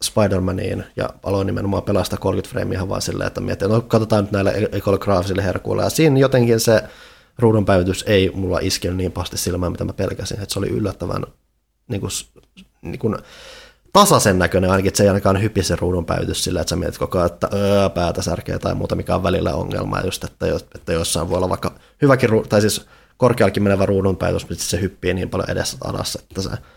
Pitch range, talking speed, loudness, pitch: 95-110 Hz, 205 wpm, -19 LUFS, 100 Hz